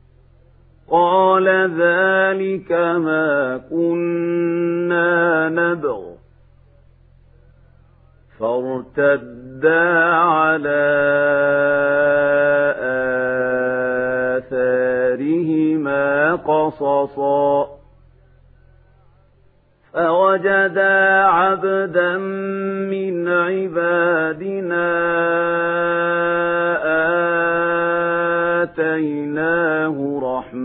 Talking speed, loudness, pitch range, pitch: 30 wpm, -17 LUFS, 135-170 Hz, 160 Hz